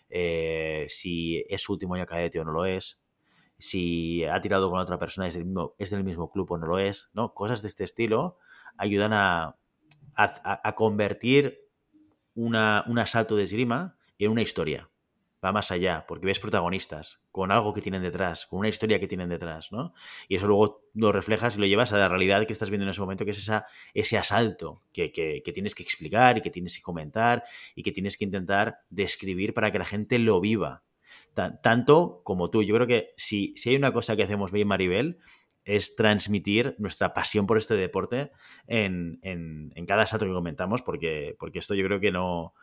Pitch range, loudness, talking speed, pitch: 90-110 Hz, -27 LUFS, 205 wpm, 100 Hz